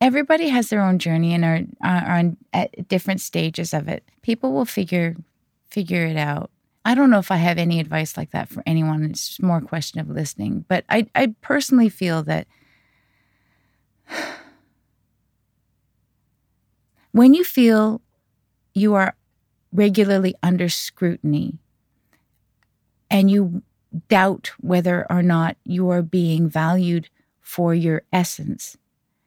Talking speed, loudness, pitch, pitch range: 135 wpm, -20 LUFS, 175 Hz, 155-195 Hz